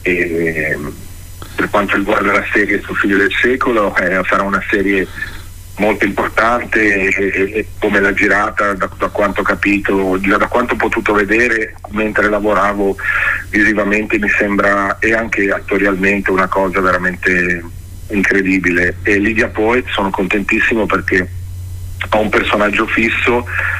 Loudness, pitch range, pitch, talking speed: -14 LUFS, 90-105 Hz, 100 Hz, 140 wpm